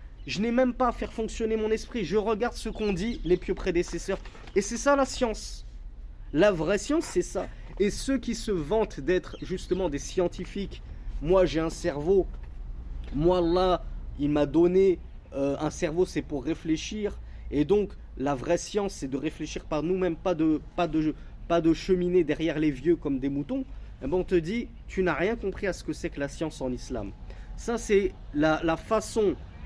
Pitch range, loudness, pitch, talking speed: 150-200 Hz, -28 LUFS, 175 Hz, 195 wpm